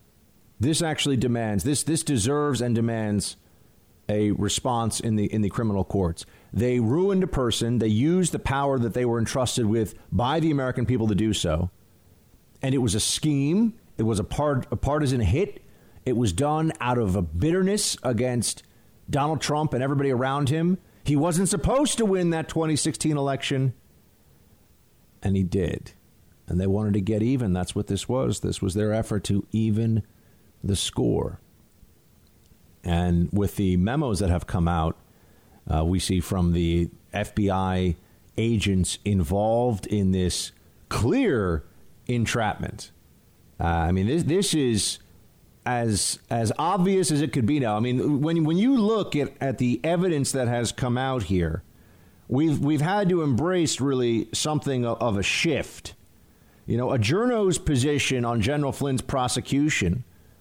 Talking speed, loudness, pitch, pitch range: 160 wpm, -24 LUFS, 115 Hz, 100-140 Hz